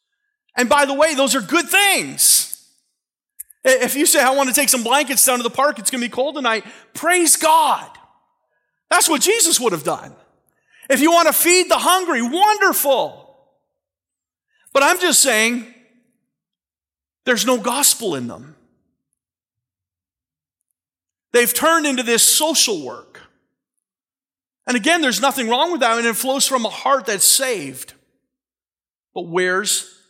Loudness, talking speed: -15 LUFS, 155 wpm